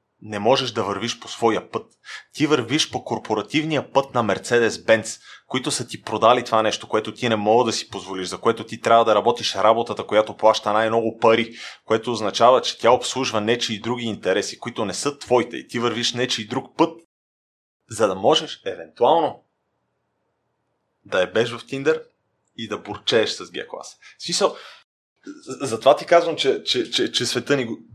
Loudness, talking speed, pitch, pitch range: -21 LUFS, 180 wpm, 120 Hz, 110-150 Hz